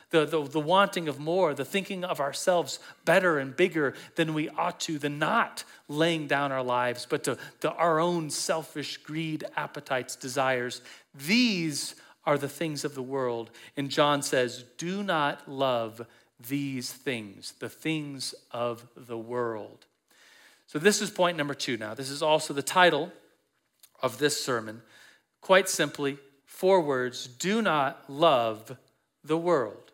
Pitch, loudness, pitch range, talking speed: 145 Hz, -28 LUFS, 130-165 Hz, 150 wpm